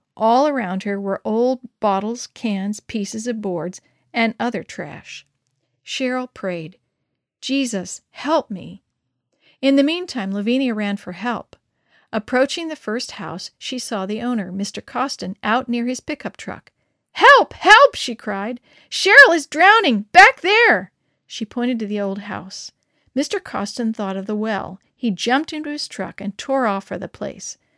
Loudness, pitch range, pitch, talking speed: -18 LUFS, 200-265 Hz, 235 Hz, 160 wpm